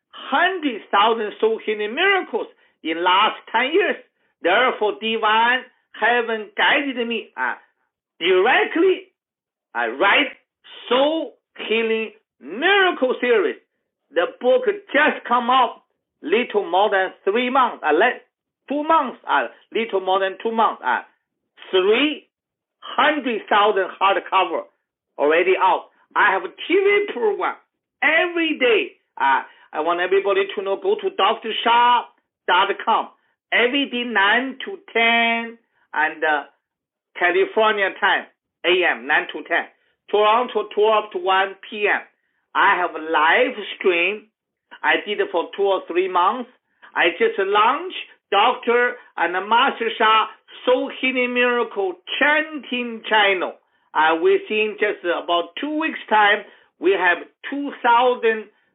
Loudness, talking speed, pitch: -19 LUFS, 125 wpm, 245 Hz